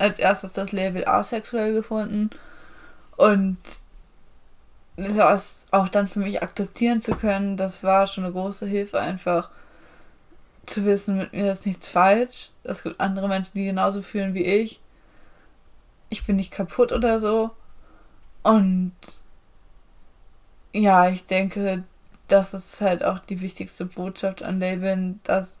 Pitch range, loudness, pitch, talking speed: 185-205 Hz, -23 LUFS, 195 Hz, 135 wpm